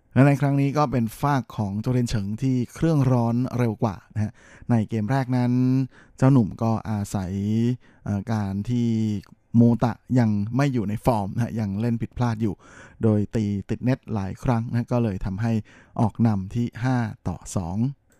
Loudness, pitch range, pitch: -24 LUFS, 105-125 Hz, 115 Hz